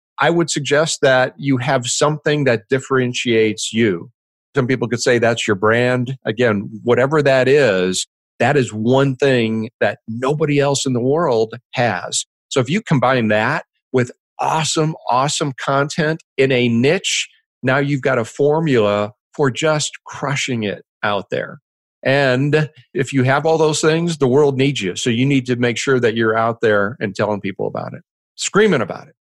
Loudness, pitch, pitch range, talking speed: -17 LUFS, 130 Hz, 115-145 Hz, 175 wpm